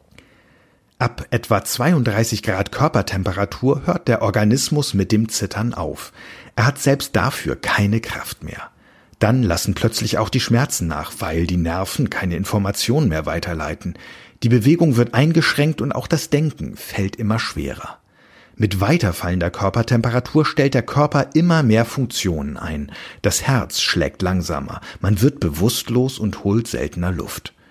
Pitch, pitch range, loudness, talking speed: 110 Hz, 95-130 Hz, -19 LUFS, 140 wpm